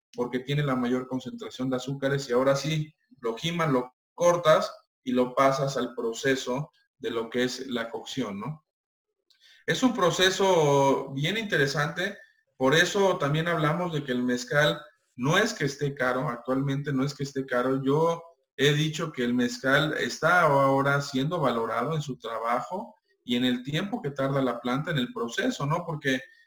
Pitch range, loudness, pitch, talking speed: 125-170 Hz, -26 LUFS, 140 Hz, 170 wpm